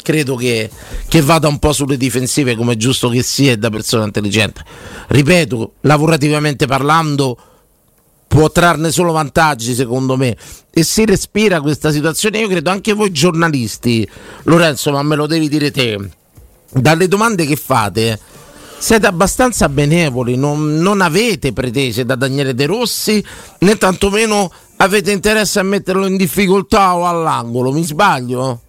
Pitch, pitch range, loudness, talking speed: 150 Hz, 130-185 Hz, -13 LUFS, 140 wpm